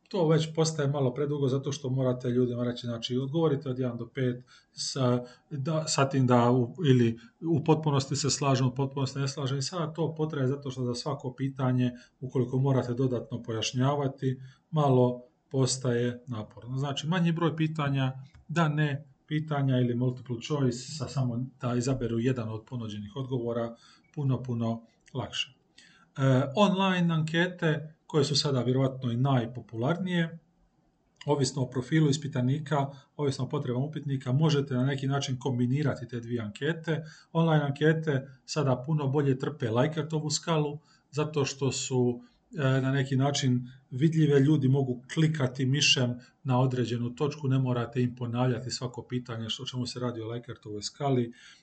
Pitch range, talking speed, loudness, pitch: 125-150 Hz, 150 wpm, -29 LUFS, 135 Hz